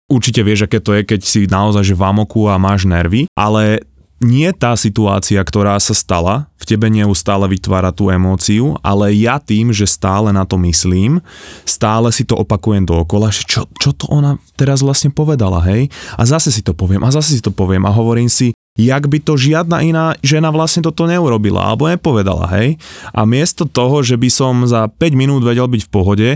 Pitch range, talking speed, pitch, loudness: 100-140 Hz, 200 wpm, 110 Hz, -12 LUFS